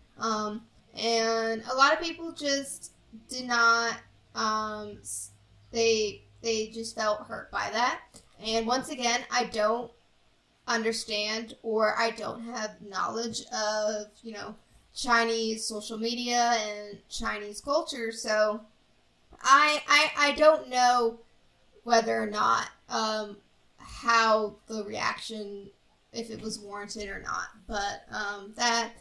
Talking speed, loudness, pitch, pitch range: 120 wpm, -28 LUFS, 225 Hz, 215-235 Hz